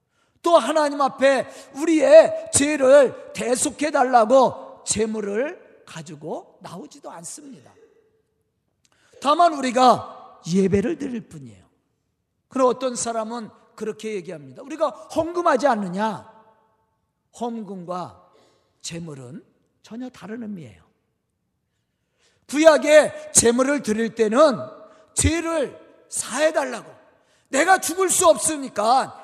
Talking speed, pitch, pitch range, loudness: 225 characters per minute, 260 Hz, 220-305 Hz, -19 LUFS